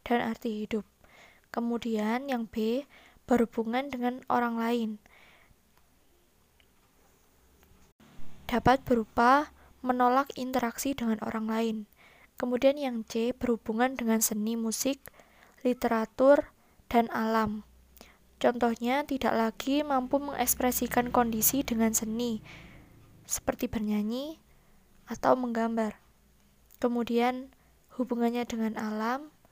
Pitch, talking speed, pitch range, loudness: 235 Hz, 85 wpm, 225-255 Hz, -29 LUFS